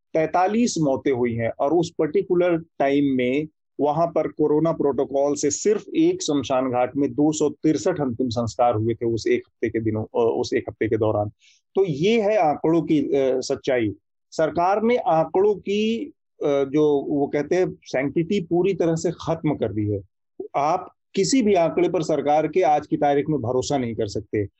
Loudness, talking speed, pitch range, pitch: -22 LUFS, 180 wpm, 135-180 Hz, 150 Hz